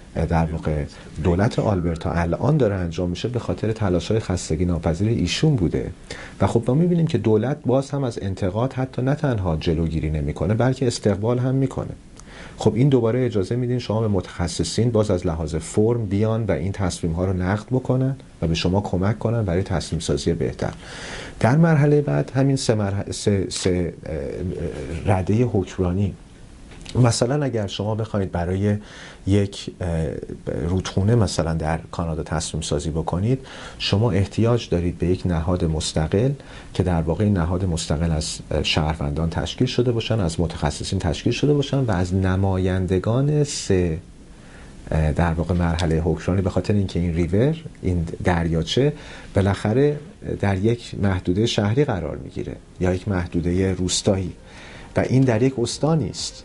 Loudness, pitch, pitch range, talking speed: -22 LUFS, 95 Hz, 85-120 Hz, 150 wpm